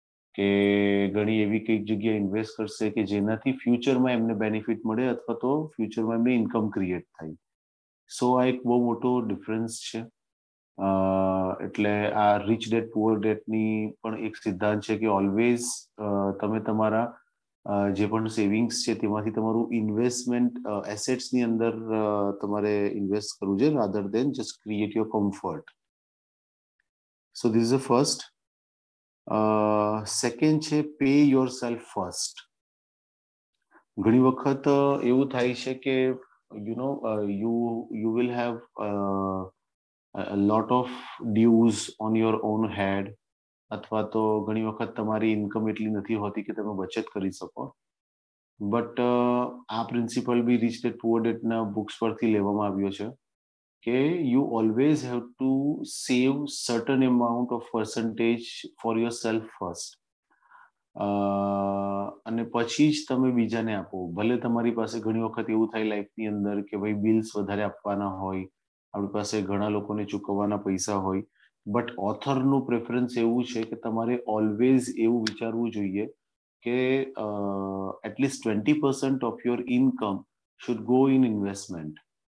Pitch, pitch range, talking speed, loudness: 110 Hz, 105-120 Hz, 130 wpm, -27 LUFS